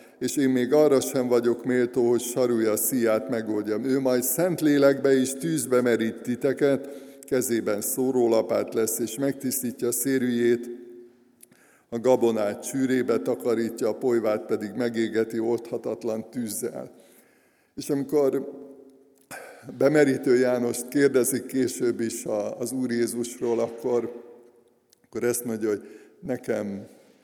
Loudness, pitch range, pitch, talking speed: -25 LUFS, 115-135 Hz, 120 Hz, 115 wpm